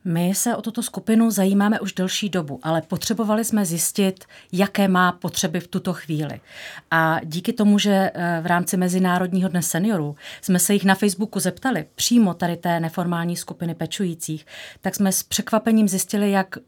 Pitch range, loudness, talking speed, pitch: 175-205 Hz, -21 LUFS, 165 wpm, 185 Hz